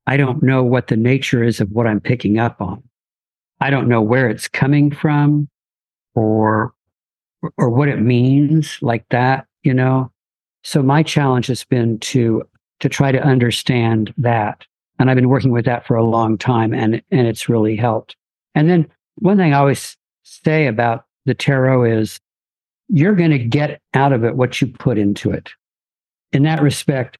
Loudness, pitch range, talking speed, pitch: -16 LUFS, 115-140 Hz, 180 wpm, 125 Hz